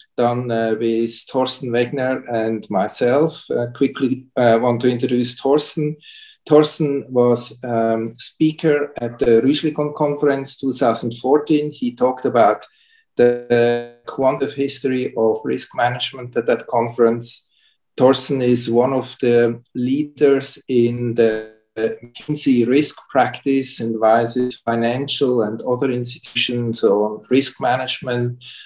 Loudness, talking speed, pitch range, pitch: -19 LUFS, 115 wpm, 120-140 Hz, 125 Hz